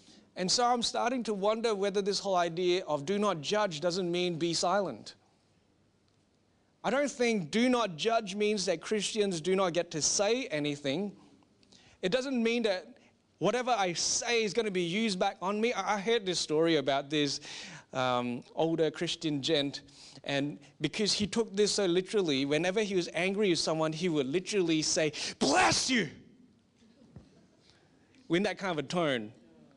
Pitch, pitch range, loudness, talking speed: 185 Hz, 155-210 Hz, -30 LUFS, 170 wpm